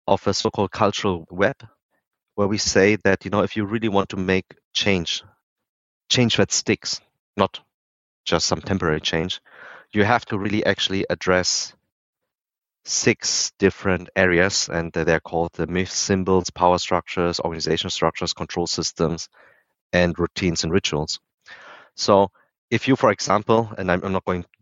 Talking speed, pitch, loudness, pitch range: 150 wpm, 95 Hz, -21 LUFS, 85-100 Hz